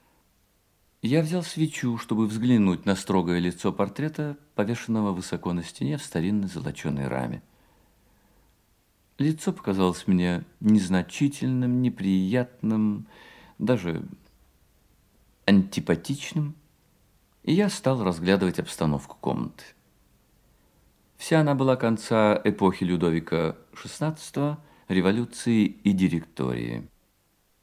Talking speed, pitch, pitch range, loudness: 85 wpm, 100 Hz, 90-125 Hz, -26 LUFS